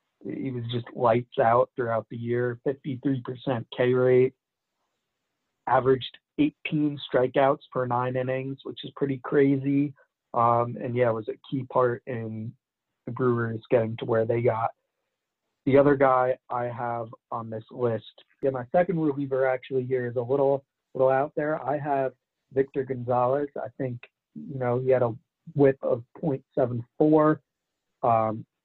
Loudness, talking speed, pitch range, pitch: -26 LUFS, 150 wpm, 120-140 Hz, 130 Hz